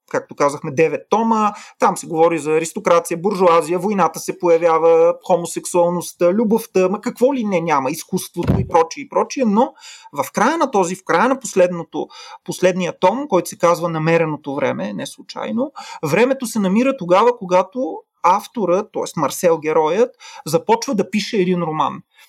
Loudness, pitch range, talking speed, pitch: -18 LUFS, 170-240 Hz, 155 wpm, 185 Hz